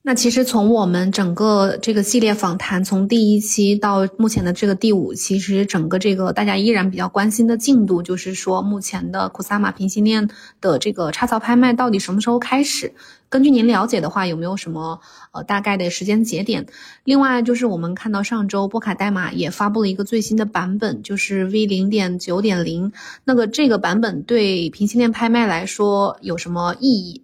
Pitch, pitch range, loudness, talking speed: 205 Hz, 190-230 Hz, -18 LUFS, 315 characters per minute